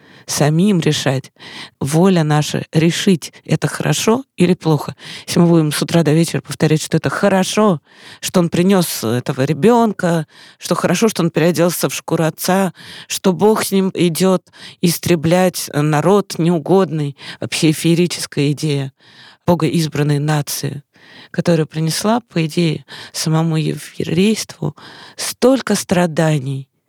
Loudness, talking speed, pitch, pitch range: -16 LUFS, 125 wpm, 165 Hz, 150-185 Hz